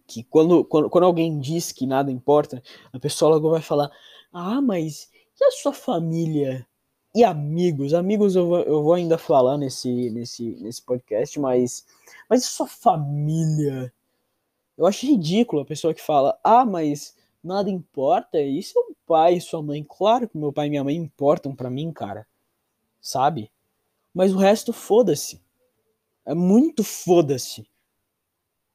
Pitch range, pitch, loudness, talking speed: 130-185 Hz, 155 Hz, -21 LUFS, 155 wpm